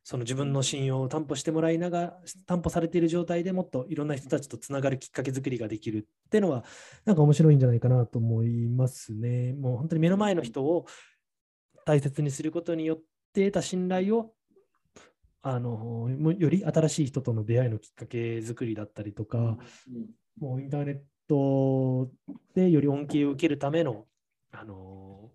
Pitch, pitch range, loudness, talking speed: 140 Hz, 120-165 Hz, -28 LUFS, 350 characters per minute